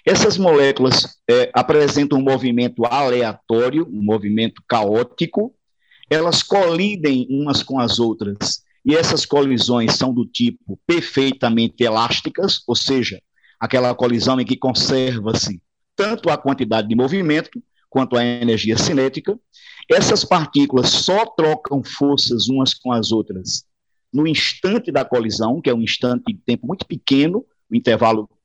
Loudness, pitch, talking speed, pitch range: -18 LUFS, 130 Hz, 135 wpm, 120-155 Hz